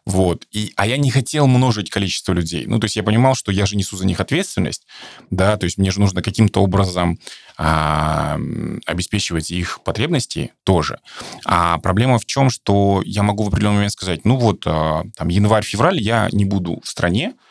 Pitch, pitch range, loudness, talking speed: 100 Hz, 90-110 Hz, -18 LUFS, 190 wpm